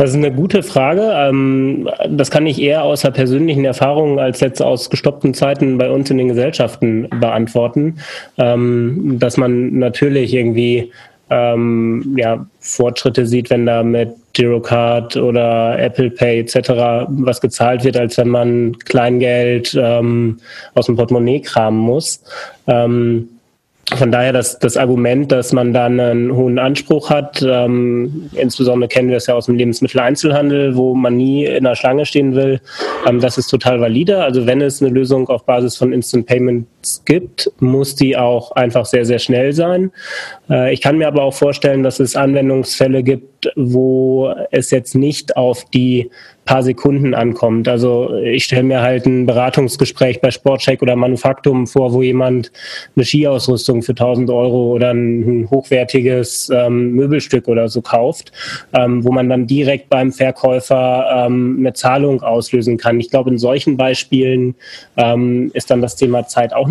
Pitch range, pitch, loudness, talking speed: 120-135 Hz, 125 Hz, -14 LUFS, 160 wpm